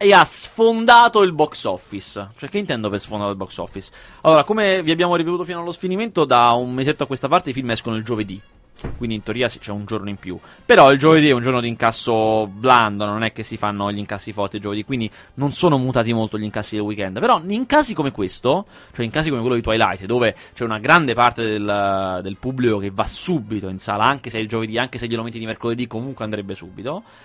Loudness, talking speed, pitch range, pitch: -19 LUFS, 240 wpm, 105-145 Hz, 115 Hz